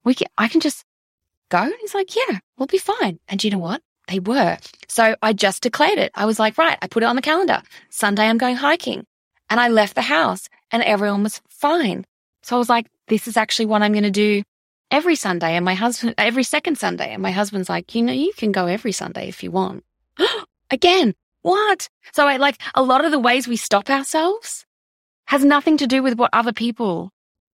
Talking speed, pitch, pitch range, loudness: 225 wpm, 240 Hz, 210-295 Hz, -19 LUFS